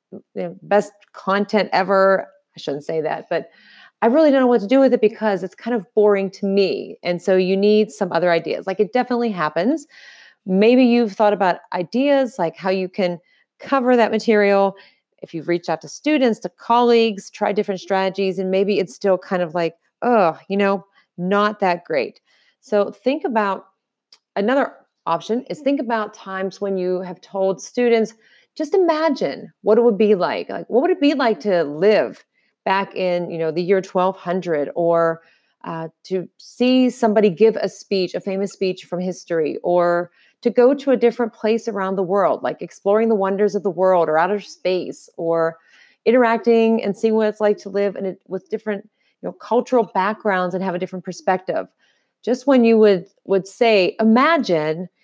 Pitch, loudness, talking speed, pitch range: 200 Hz, -19 LUFS, 185 wpm, 185-230 Hz